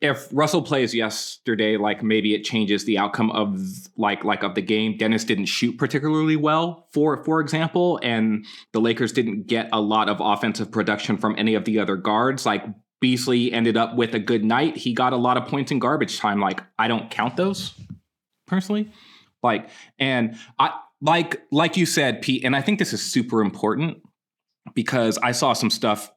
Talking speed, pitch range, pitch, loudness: 190 wpm, 110-150 Hz, 120 Hz, -22 LUFS